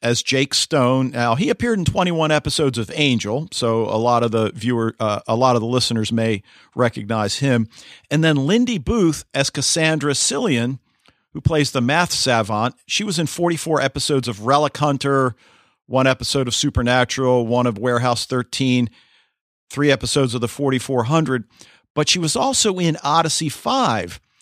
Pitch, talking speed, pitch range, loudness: 130 Hz, 160 wpm, 120-150 Hz, -19 LUFS